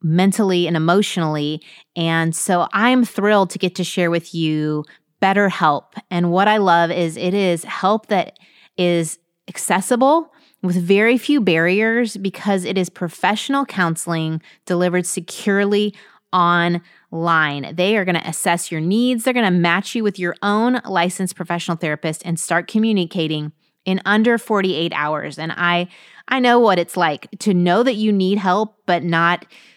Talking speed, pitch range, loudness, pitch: 155 wpm, 170-205 Hz, -18 LUFS, 180 Hz